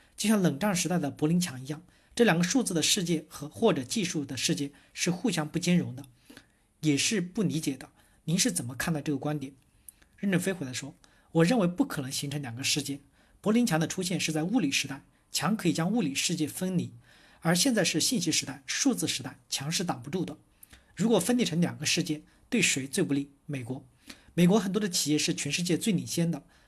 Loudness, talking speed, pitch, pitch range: -28 LUFS, 315 characters per minute, 160 Hz, 145-185 Hz